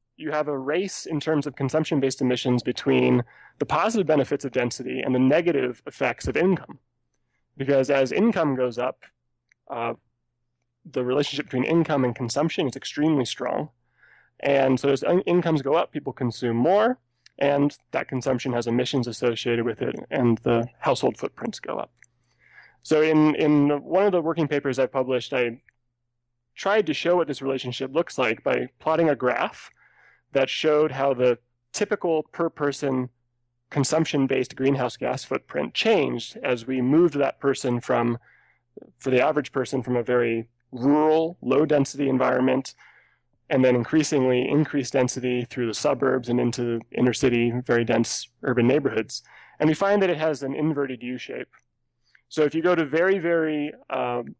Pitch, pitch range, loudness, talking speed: 135 Hz, 125-150 Hz, -24 LUFS, 165 wpm